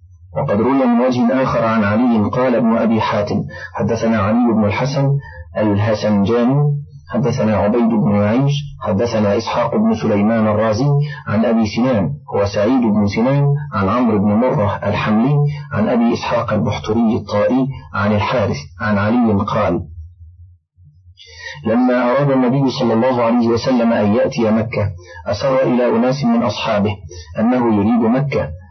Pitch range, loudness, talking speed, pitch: 105-130 Hz, -16 LUFS, 135 wpm, 115 Hz